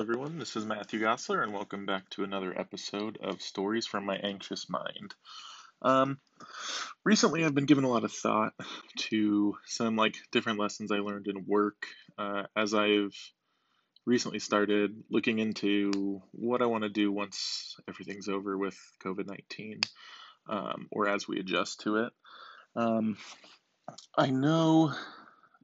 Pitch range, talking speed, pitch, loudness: 100-115 Hz, 145 wpm, 105 Hz, -31 LUFS